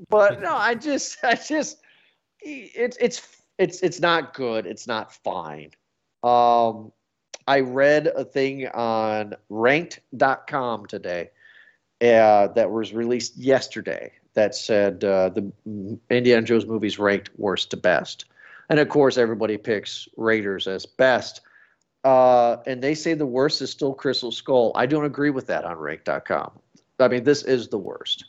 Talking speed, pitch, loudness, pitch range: 150 wpm, 125 Hz, -22 LUFS, 110-145 Hz